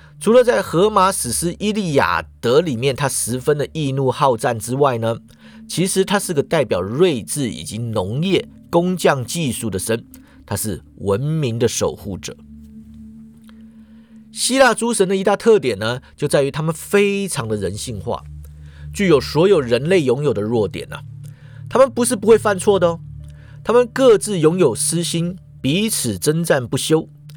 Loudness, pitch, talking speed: -18 LUFS, 145 Hz, 240 characters per minute